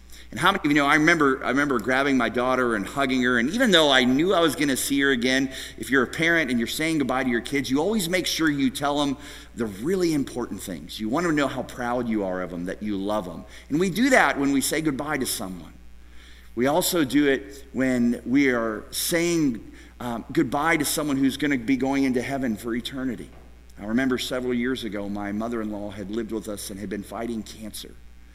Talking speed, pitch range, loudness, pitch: 240 wpm, 105-140 Hz, -23 LUFS, 125 Hz